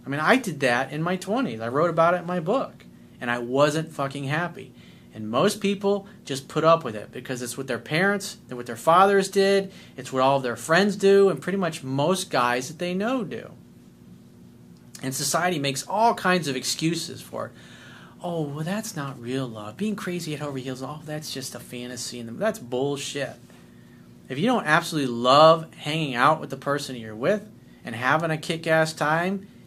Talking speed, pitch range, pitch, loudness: 200 wpm, 125-180 Hz, 150 Hz, -24 LUFS